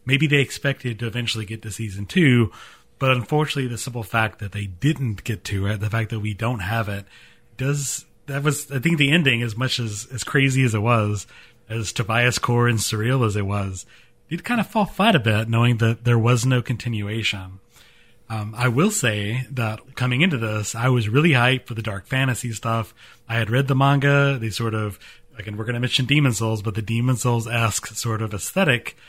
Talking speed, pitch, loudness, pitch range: 210 wpm, 120 Hz, -21 LUFS, 110-130 Hz